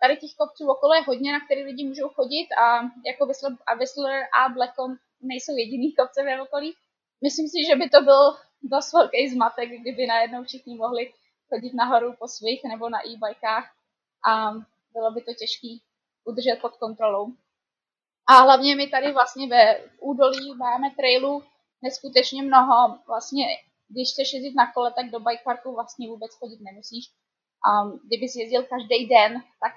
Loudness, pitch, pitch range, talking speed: -22 LUFS, 255 Hz, 235-275 Hz, 165 wpm